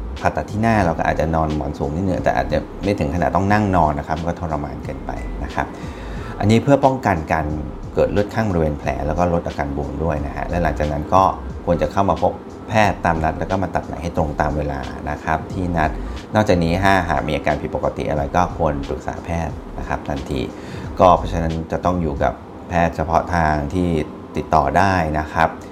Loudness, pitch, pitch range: -20 LUFS, 80 Hz, 75-90 Hz